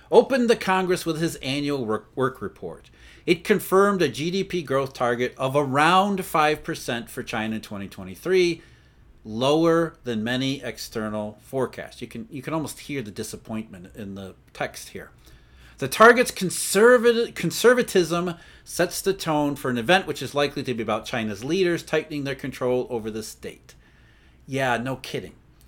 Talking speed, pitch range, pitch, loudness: 150 wpm, 120-175 Hz, 140 Hz, -23 LUFS